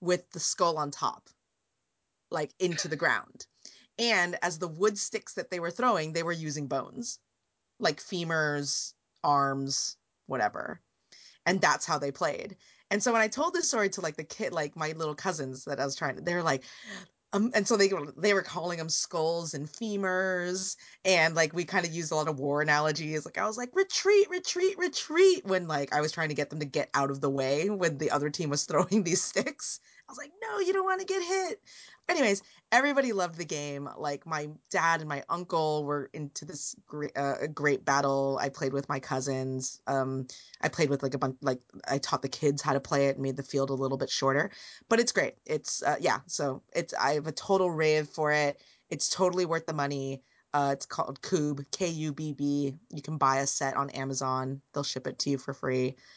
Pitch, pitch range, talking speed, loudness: 155 Hz, 140-185 Hz, 215 wpm, -30 LUFS